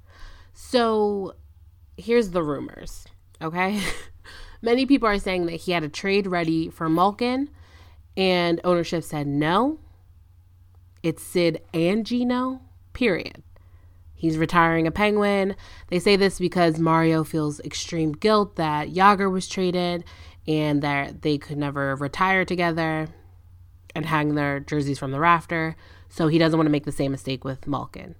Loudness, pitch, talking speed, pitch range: -23 LUFS, 160 Hz, 145 wpm, 120-180 Hz